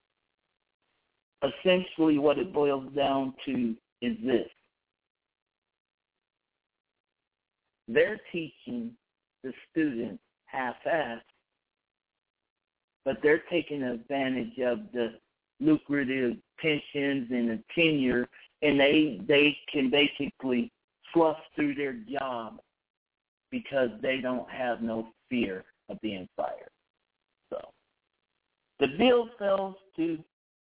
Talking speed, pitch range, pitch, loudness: 90 wpm, 125-185 Hz, 145 Hz, -29 LUFS